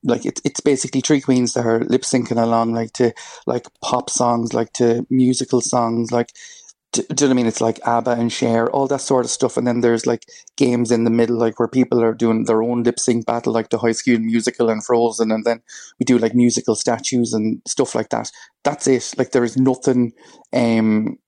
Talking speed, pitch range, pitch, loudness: 225 wpm, 115-125 Hz, 120 Hz, -18 LUFS